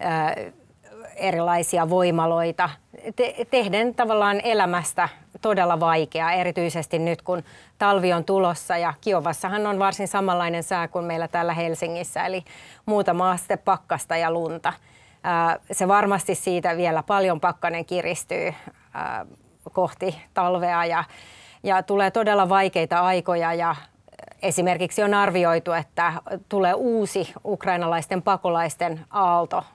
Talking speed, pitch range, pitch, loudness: 105 wpm, 170-195 Hz, 180 Hz, -23 LUFS